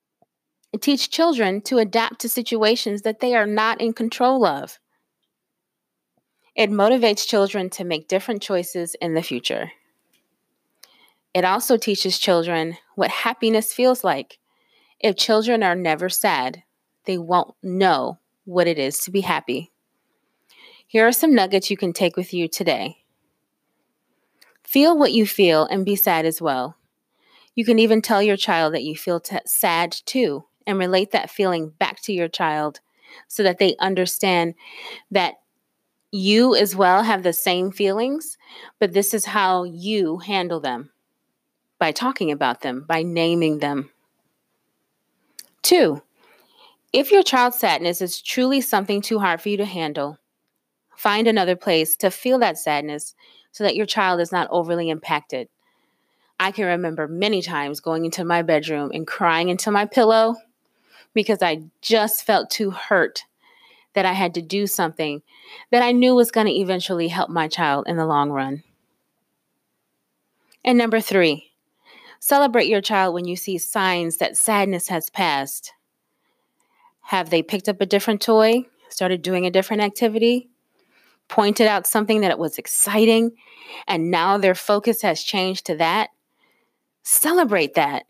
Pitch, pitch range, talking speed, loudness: 195 Hz, 175-225 Hz, 150 wpm, -20 LUFS